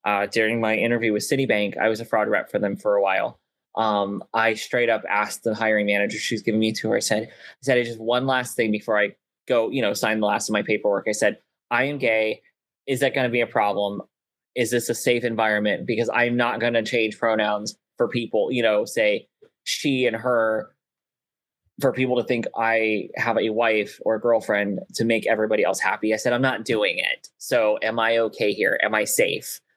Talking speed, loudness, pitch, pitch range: 225 wpm, -22 LUFS, 115 Hz, 110-125 Hz